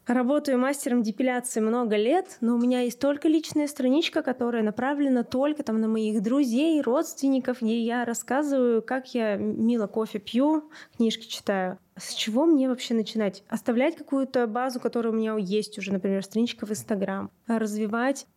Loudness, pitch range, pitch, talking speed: -26 LUFS, 220-270 Hz, 240 Hz, 155 wpm